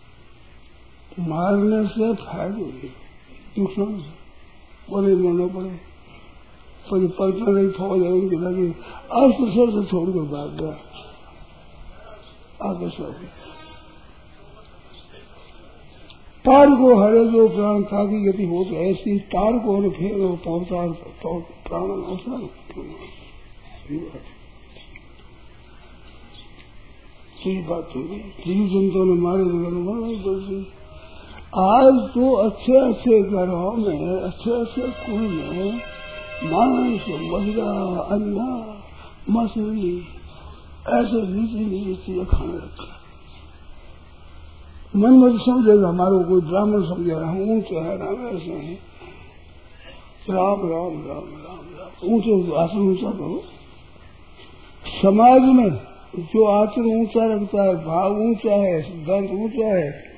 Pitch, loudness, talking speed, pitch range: 190 Hz, -20 LUFS, 75 wpm, 165-210 Hz